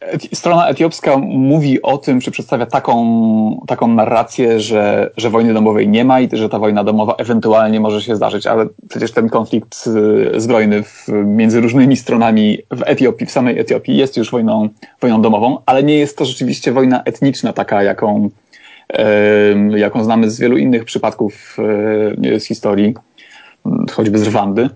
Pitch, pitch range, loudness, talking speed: 110 Hz, 105-125 Hz, -13 LUFS, 160 wpm